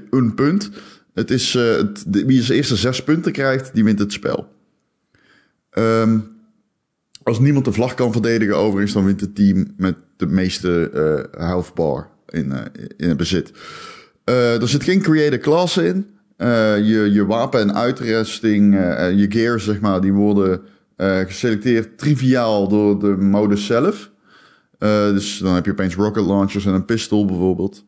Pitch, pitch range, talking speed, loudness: 105 Hz, 100-120 Hz, 170 wpm, -18 LUFS